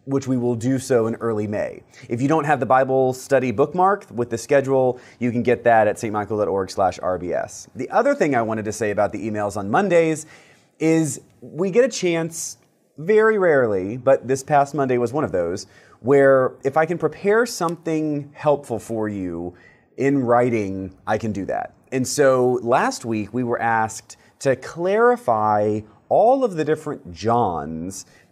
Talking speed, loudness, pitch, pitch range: 170 wpm, -20 LUFS, 130 Hz, 110-155 Hz